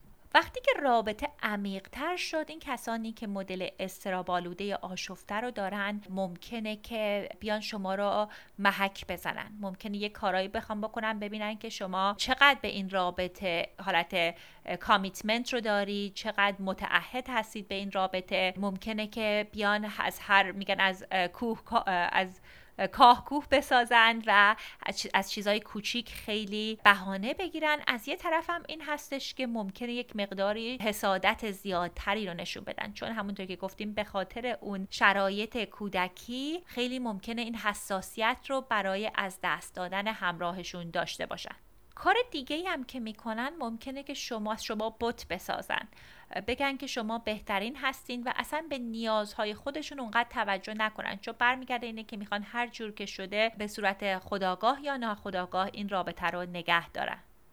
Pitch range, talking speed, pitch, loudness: 195-240 Hz, 150 wpm, 210 Hz, -31 LUFS